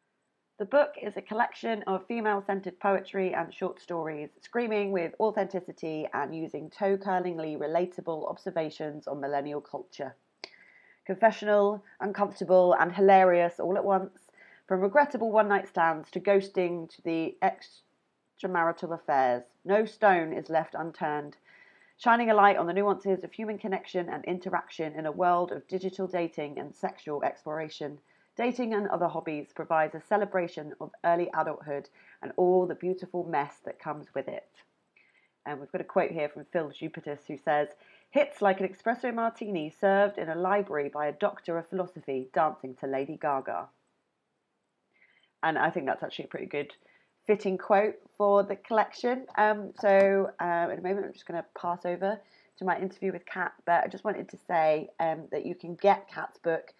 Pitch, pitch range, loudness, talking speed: 185 Hz, 160-200 Hz, -29 LUFS, 165 wpm